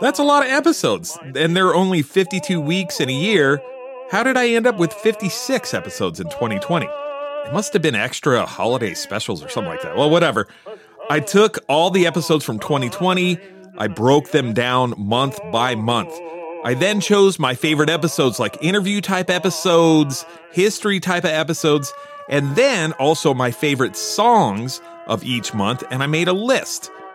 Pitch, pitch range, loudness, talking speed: 170 Hz, 145-205 Hz, -18 LUFS, 175 wpm